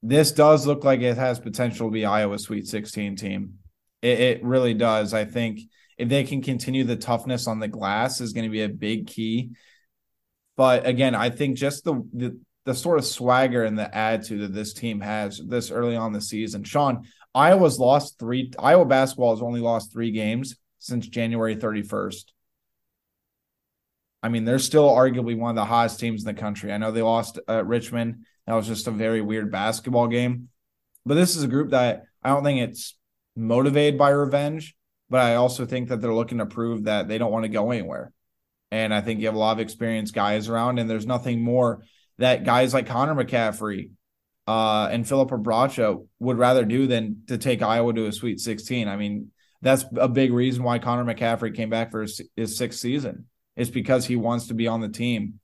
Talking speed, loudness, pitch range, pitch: 205 wpm, -23 LUFS, 110-125 Hz, 115 Hz